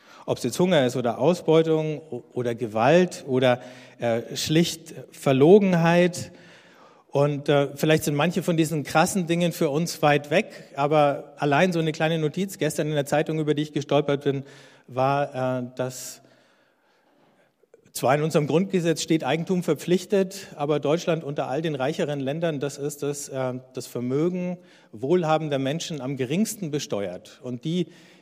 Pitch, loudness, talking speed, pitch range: 150 Hz, -24 LUFS, 150 wpm, 140-170 Hz